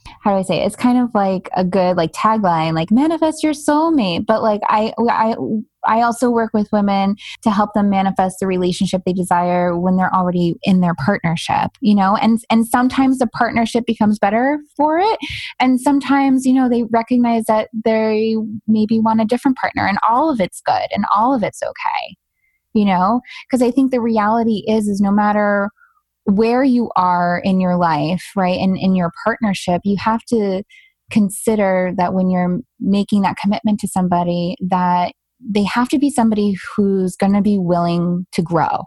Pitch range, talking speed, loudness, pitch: 185-235 Hz, 185 wpm, -16 LUFS, 210 Hz